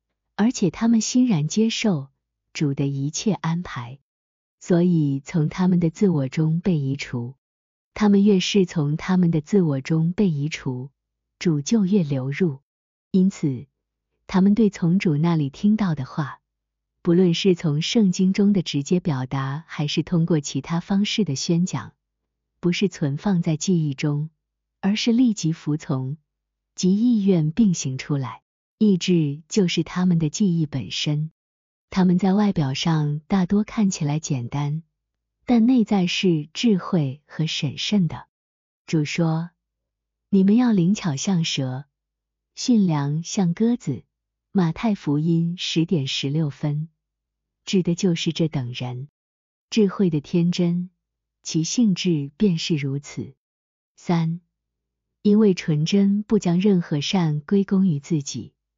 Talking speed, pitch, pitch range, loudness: 195 characters per minute, 165 Hz, 145-195 Hz, -22 LUFS